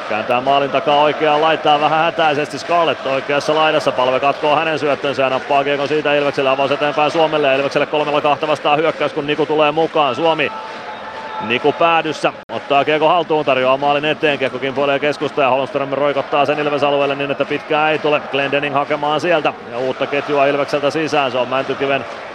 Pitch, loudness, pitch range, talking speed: 145 Hz, -16 LUFS, 140-150 Hz, 175 wpm